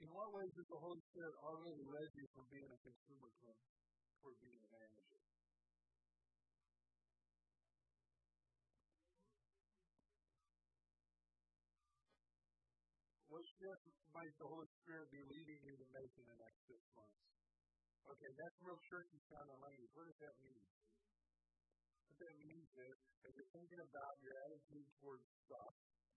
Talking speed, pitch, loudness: 130 wpm, 130 Hz, -60 LUFS